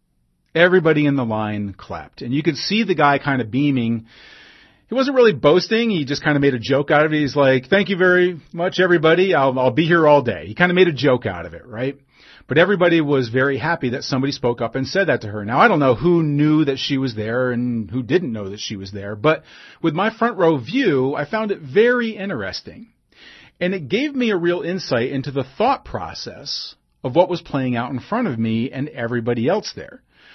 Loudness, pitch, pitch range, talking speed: -18 LUFS, 145 Hz, 125-175 Hz, 235 wpm